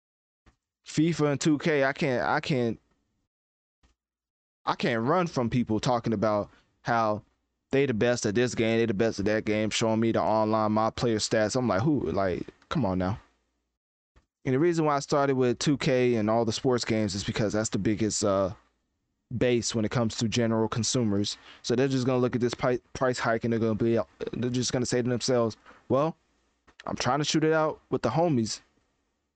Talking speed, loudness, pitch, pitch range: 200 wpm, -27 LUFS, 115 Hz, 105-125 Hz